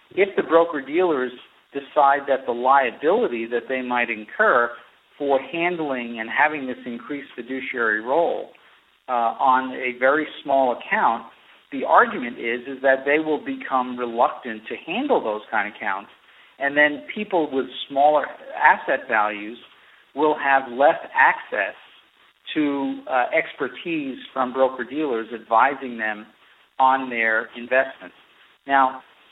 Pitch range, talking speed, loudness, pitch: 120-145 Hz, 125 wpm, -22 LUFS, 130 Hz